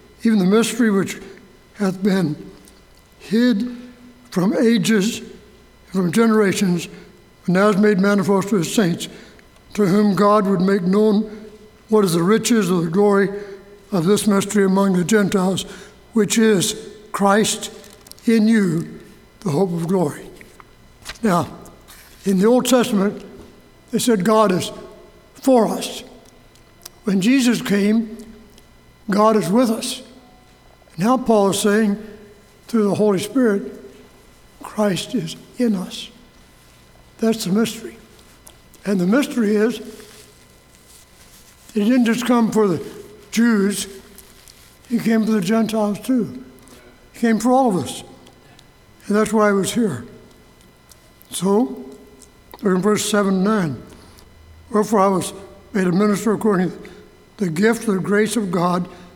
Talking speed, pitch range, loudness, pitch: 135 wpm, 195-220 Hz, -18 LUFS, 205 Hz